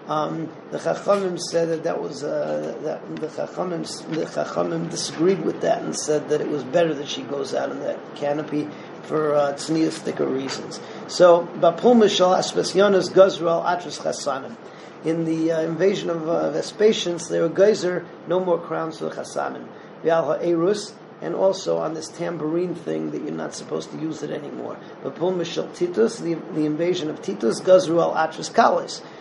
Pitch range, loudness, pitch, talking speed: 155-180 Hz, -22 LUFS, 170 Hz, 175 wpm